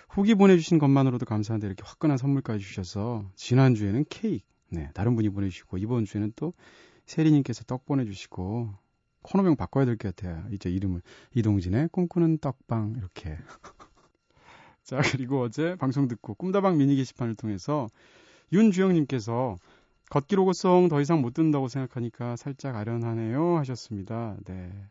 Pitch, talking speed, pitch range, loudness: 125 Hz, 360 characters per minute, 105-145 Hz, -27 LUFS